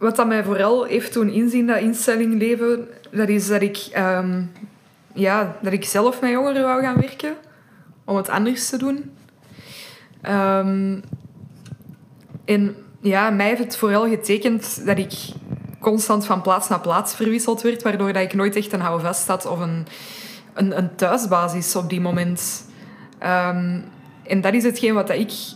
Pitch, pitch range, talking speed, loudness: 205 Hz, 185-230 Hz, 160 wpm, -20 LUFS